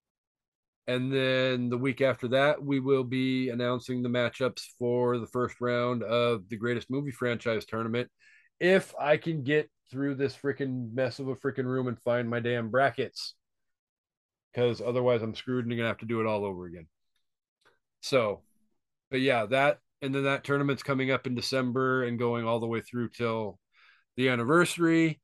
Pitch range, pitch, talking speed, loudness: 120-135 Hz, 125 Hz, 175 wpm, -29 LUFS